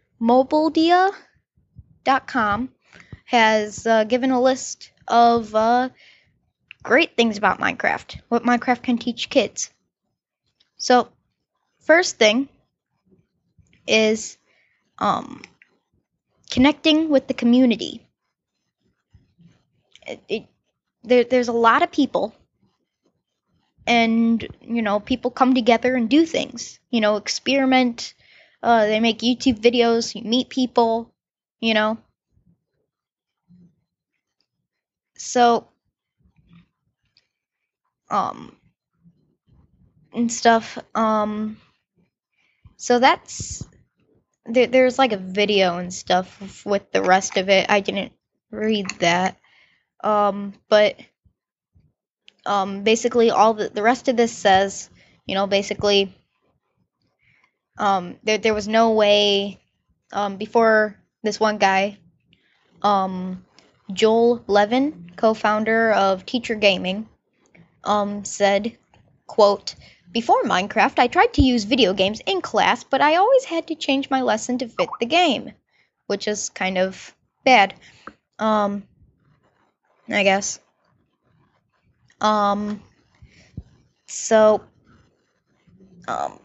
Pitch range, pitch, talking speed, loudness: 200-250 Hz, 220 Hz, 105 wpm, -19 LUFS